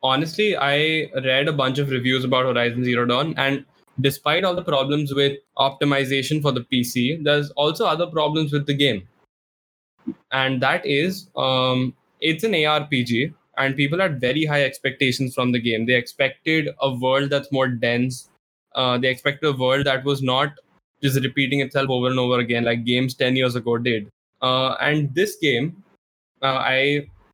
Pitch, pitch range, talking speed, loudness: 135 Hz, 125-145 Hz, 170 wpm, -21 LUFS